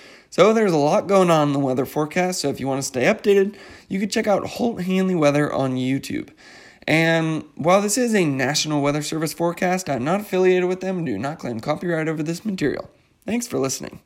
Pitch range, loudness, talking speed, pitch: 145-190 Hz, -21 LUFS, 220 wpm, 165 Hz